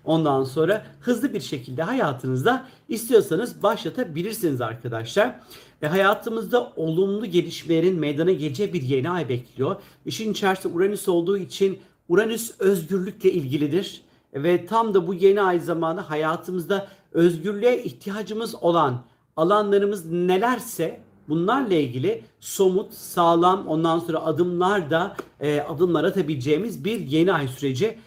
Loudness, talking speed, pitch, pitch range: -23 LUFS, 115 wpm, 180 Hz, 160-200 Hz